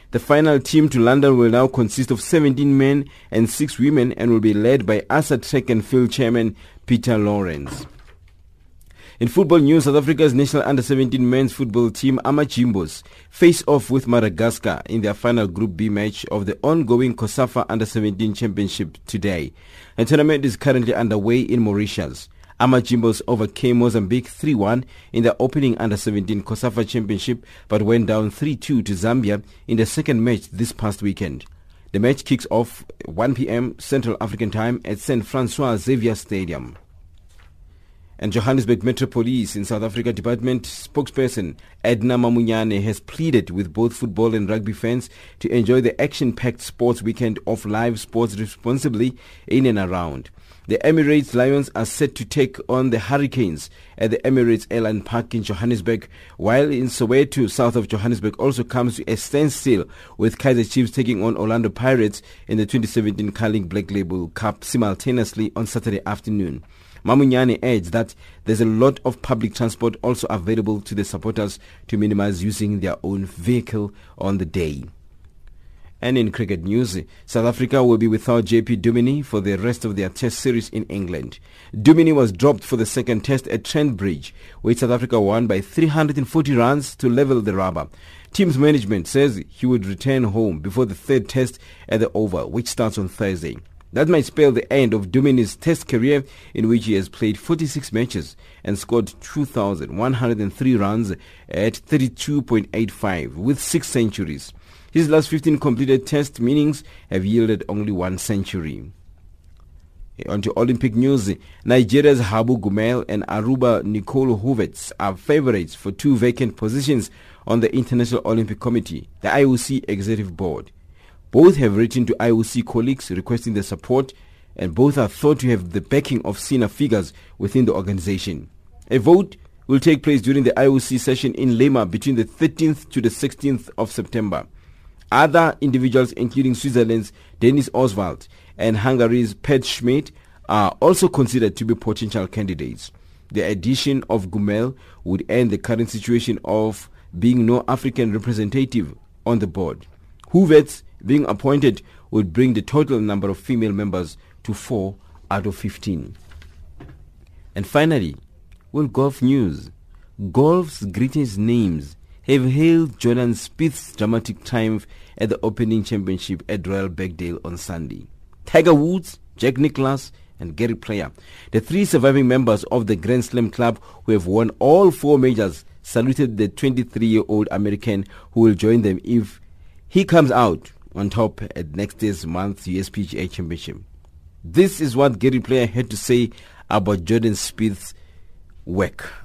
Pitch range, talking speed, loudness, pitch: 95-130 Hz, 155 wpm, -19 LUFS, 115 Hz